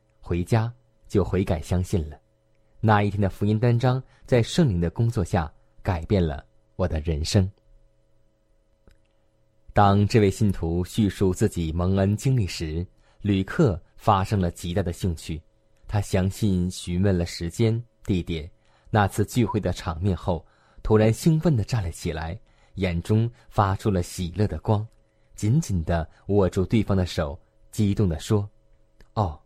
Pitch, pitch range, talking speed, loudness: 105 Hz, 90-110 Hz, 210 characters per minute, -25 LUFS